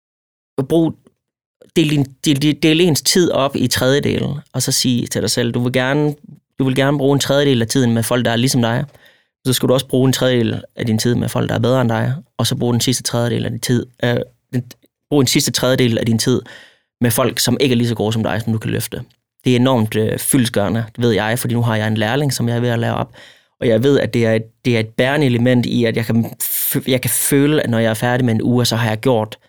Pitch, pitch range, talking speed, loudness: 125 Hz, 115-130 Hz, 260 wpm, -16 LUFS